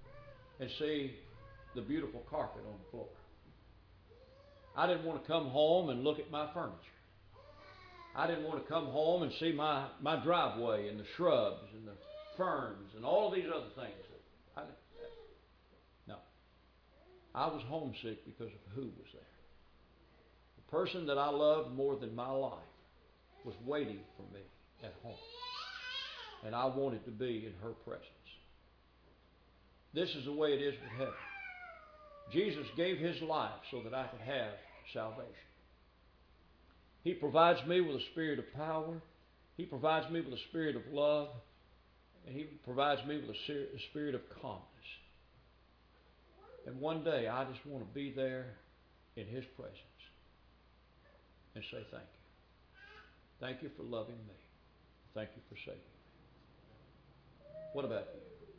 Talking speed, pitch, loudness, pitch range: 155 wpm, 135 Hz, -38 LUFS, 100-160 Hz